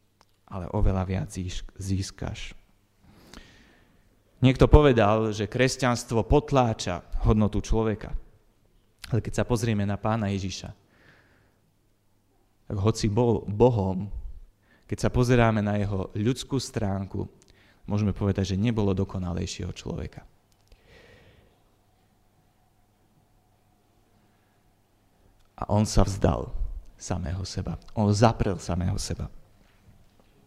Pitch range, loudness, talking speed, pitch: 95-110 Hz, -26 LUFS, 90 wpm, 100 Hz